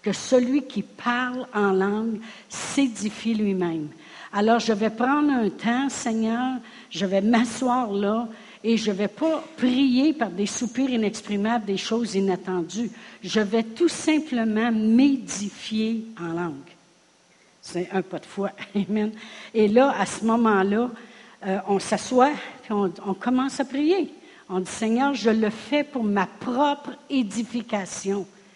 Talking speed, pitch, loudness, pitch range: 145 wpm, 225 Hz, -24 LUFS, 200-250 Hz